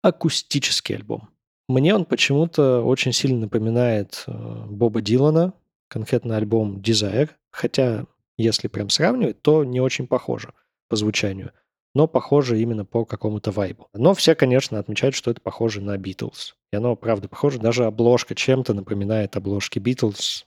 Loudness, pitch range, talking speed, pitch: -21 LUFS, 105-135 Hz, 140 wpm, 120 Hz